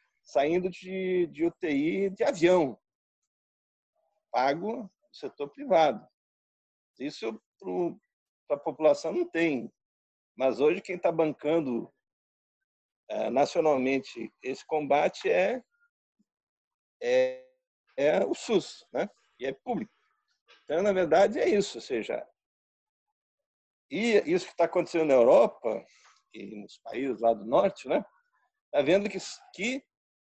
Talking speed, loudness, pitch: 115 wpm, -28 LUFS, 185 Hz